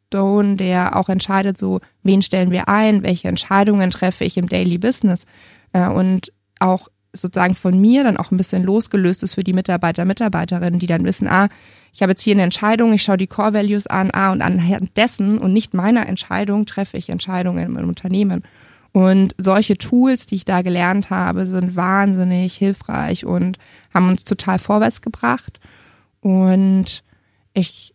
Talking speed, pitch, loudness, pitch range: 170 wpm, 190 Hz, -17 LUFS, 180-200 Hz